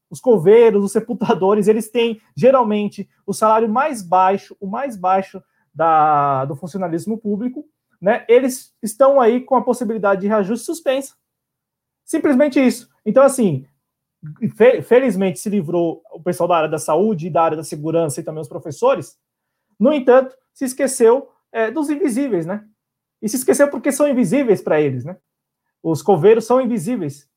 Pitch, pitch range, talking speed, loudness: 215 Hz, 180-255 Hz, 155 wpm, -17 LUFS